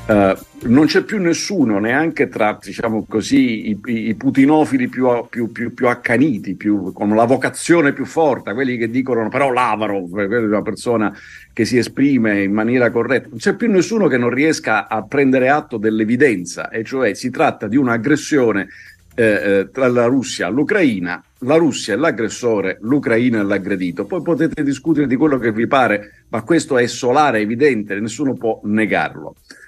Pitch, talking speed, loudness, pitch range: 120 Hz, 170 wpm, -17 LUFS, 110-145 Hz